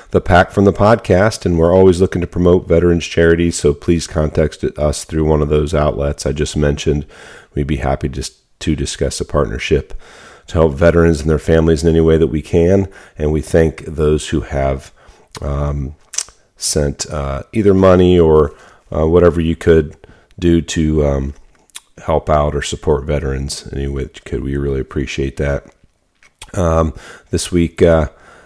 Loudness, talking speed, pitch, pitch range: -15 LUFS, 170 wpm, 80 Hz, 70-85 Hz